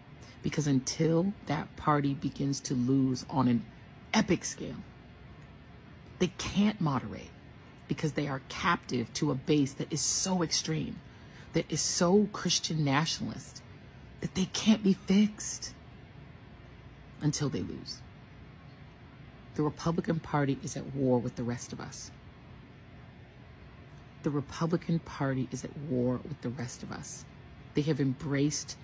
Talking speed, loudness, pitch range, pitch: 130 wpm, -31 LUFS, 130-165 Hz, 145 Hz